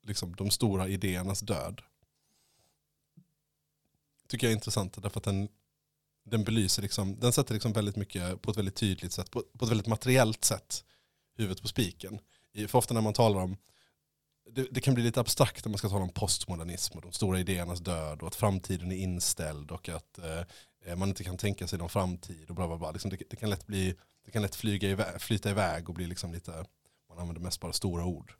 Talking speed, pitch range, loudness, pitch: 205 wpm, 90-110 Hz, -32 LUFS, 100 Hz